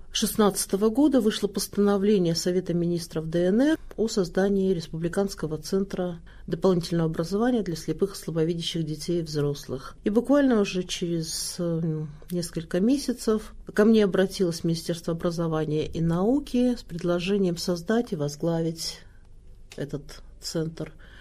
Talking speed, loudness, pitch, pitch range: 115 wpm, -26 LUFS, 175 Hz, 165-200 Hz